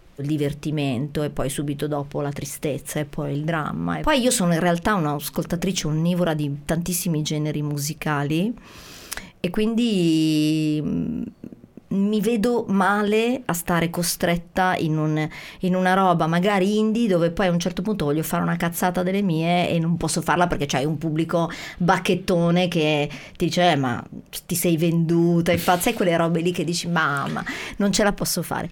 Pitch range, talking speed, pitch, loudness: 155-185 Hz, 175 wpm, 170 Hz, -22 LUFS